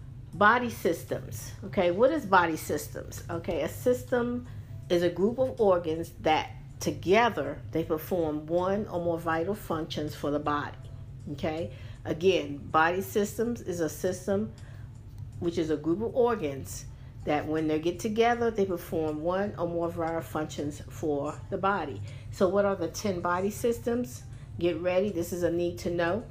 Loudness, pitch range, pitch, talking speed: -29 LUFS, 145-195 Hz, 165 Hz, 160 wpm